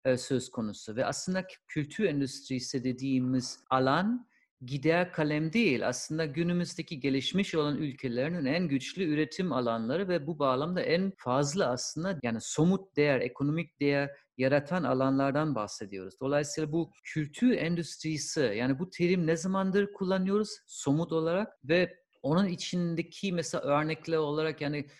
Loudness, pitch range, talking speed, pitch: -31 LUFS, 135-175 Hz, 125 wpm, 155 Hz